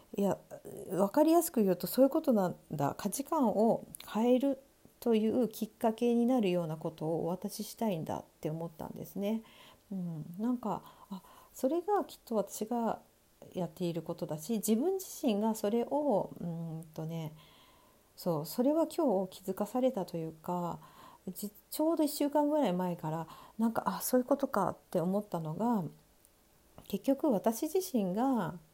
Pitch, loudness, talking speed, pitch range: 210 Hz, -33 LUFS, 310 characters per minute, 175-255 Hz